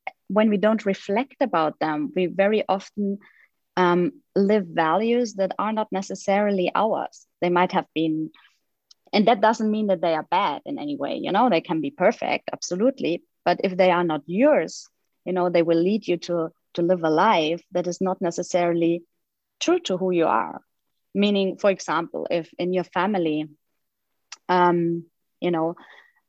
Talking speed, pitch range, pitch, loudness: 170 wpm, 170-210 Hz, 185 Hz, -23 LUFS